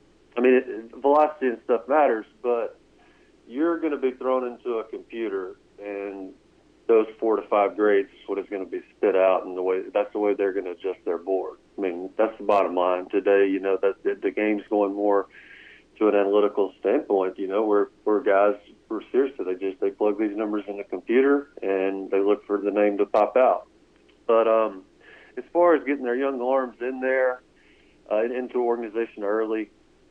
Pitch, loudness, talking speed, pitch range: 115 Hz, -24 LUFS, 200 wpm, 100-170 Hz